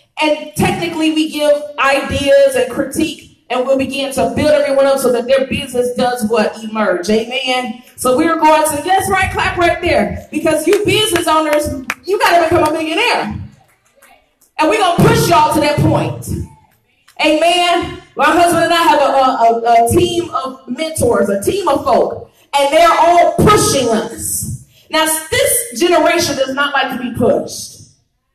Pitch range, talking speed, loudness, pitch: 265-335 Hz, 170 wpm, -13 LUFS, 300 Hz